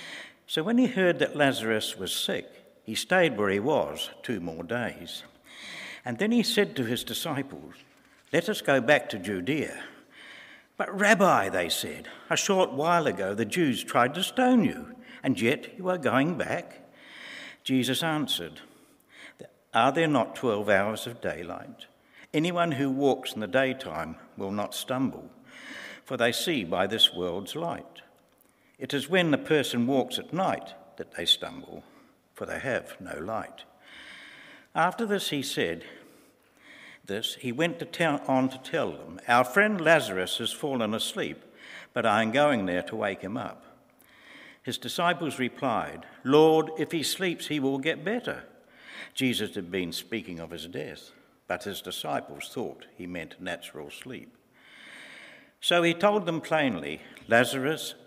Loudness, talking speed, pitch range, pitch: -27 LUFS, 155 wpm, 120-175 Hz, 140 Hz